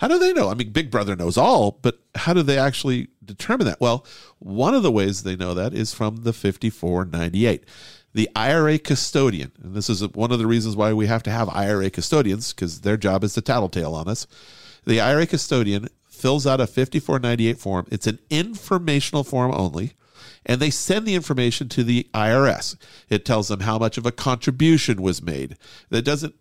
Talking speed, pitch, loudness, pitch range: 200 wpm, 115 Hz, -21 LUFS, 105-135 Hz